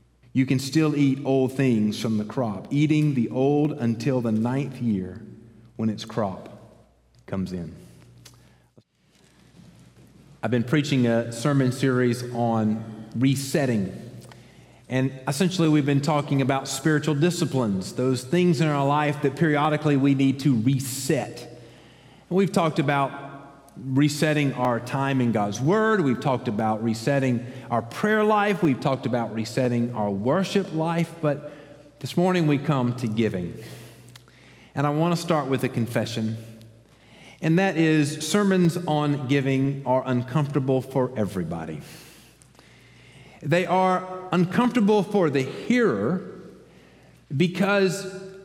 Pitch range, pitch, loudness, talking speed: 120-160 Hz, 135 Hz, -24 LUFS, 130 wpm